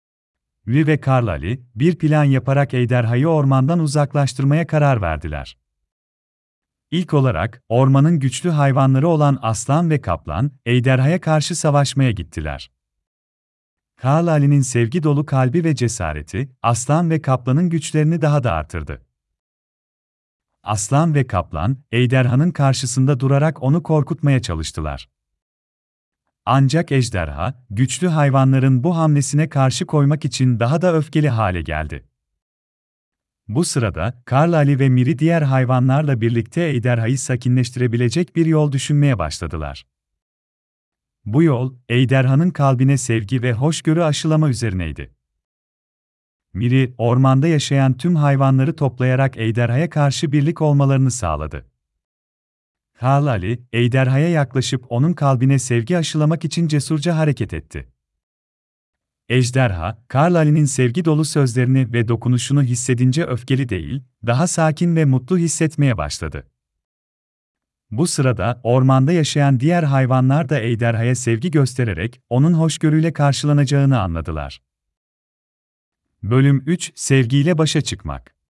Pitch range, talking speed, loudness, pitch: 90-150 Hz, 110 wpm, -17 LUFS, 130 Hz